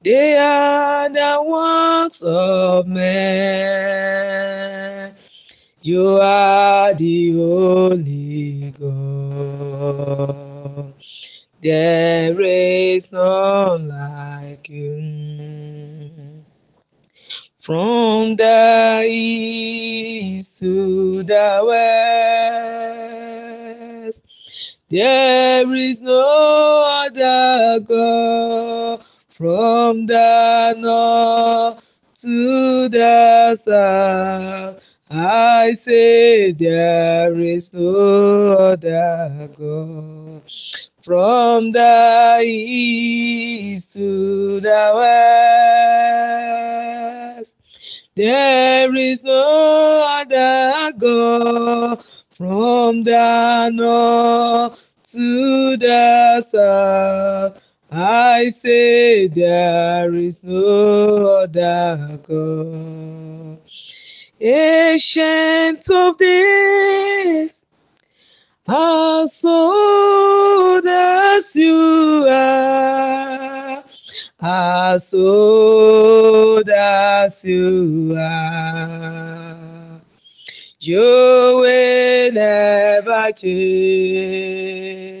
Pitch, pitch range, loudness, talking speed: 225 Hz, 185-250 Hz, -14 LUFS, 55 wpm